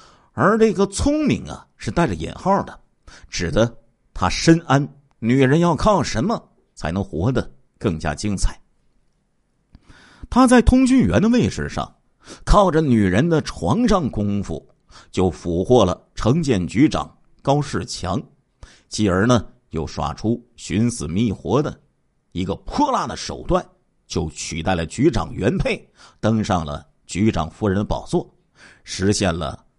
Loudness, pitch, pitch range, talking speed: -20 LUFS, 105 Hz, 85-135 Hz, 200 characters per minute